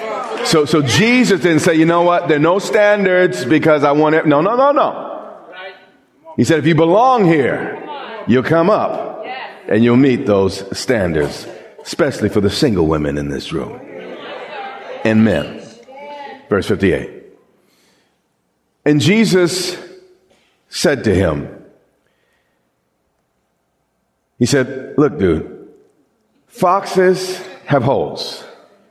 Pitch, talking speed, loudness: 165 Hz, 120 wpm, -14 LUFS